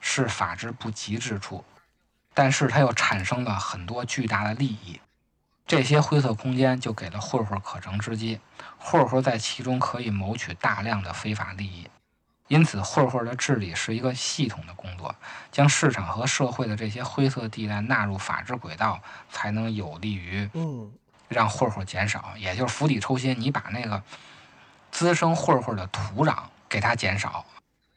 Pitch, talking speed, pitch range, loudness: 110 Hz, 255 characters per minute, 100-130 Hz, -26 LUFS